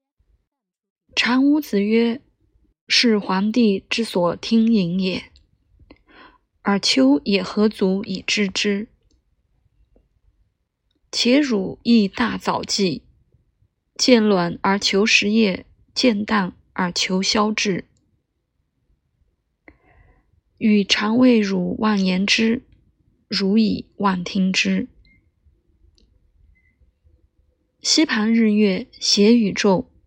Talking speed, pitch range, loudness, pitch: 115 characters per minute, 185-225 Hz, -19 LUFS, 205 Hz